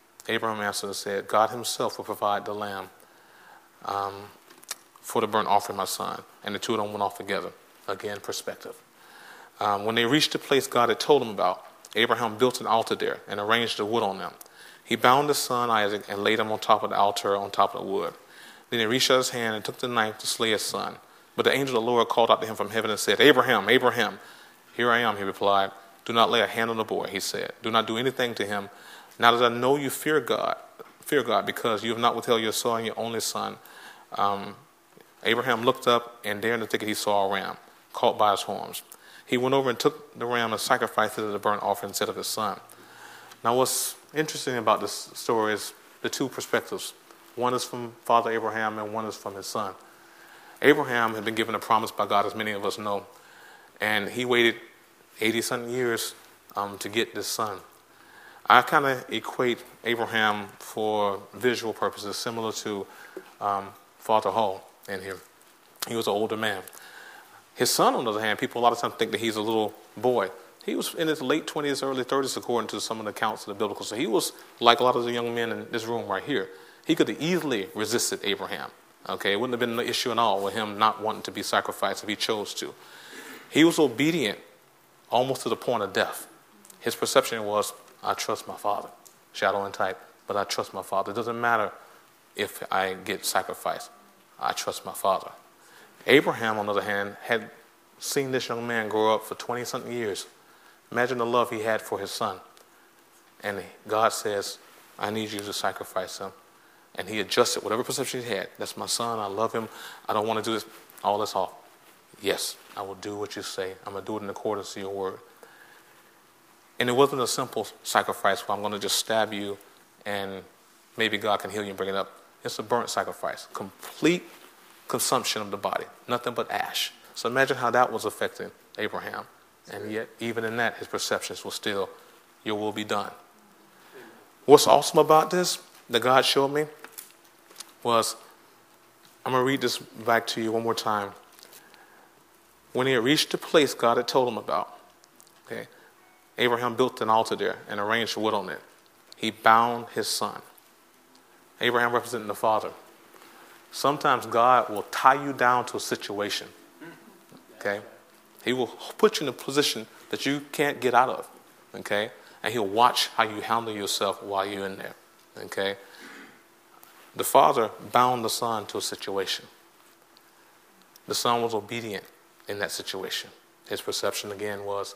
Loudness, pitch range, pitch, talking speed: -26 LUFS, 105-125 Hz, 115 Hz, 200 wpm